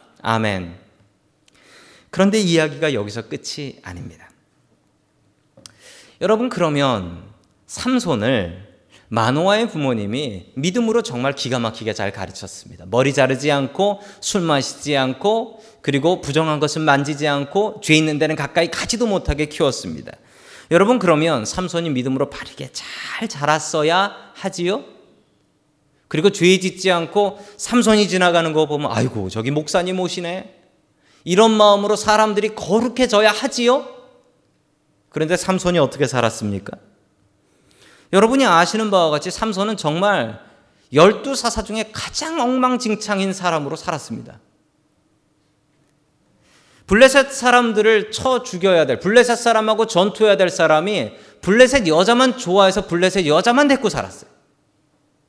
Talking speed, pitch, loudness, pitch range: 295 characters per minute, 180 Hz, -17 LUFS, 145-215 Hz